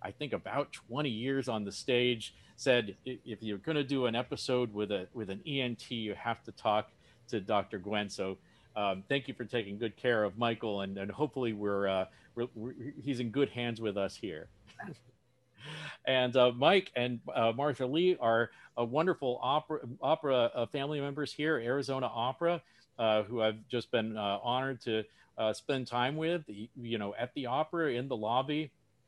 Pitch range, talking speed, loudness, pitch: 110-135 Hz, 185 wpm, -33 LUFS, 120 Hz